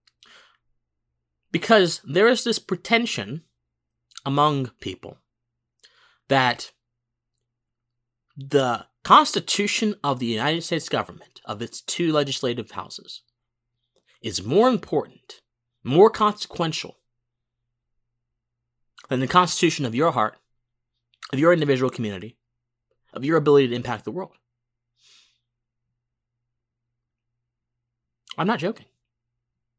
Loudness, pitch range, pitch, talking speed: -22 LUFS, 120-145 Hz, 120 Hz, 90 wpm